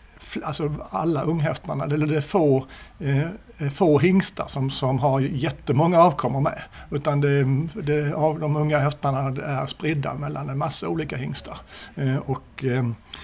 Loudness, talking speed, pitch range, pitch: -24 LUFS, 150 wpm, 135-155 Hz, 145 Hz